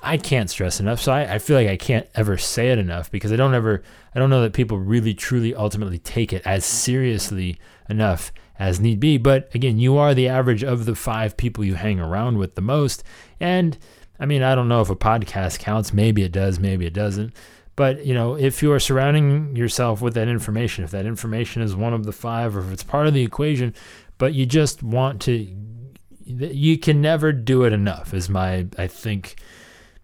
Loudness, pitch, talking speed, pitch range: -21 LUFS, 115 Hz, 215 wpm, 100-130 Hz